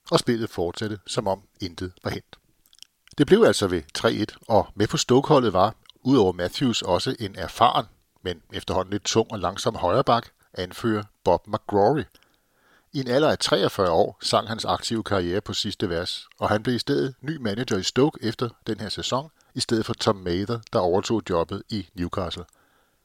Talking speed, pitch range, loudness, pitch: 180 wpm, 95-120 Hz, -24 LUFS, 105 Hz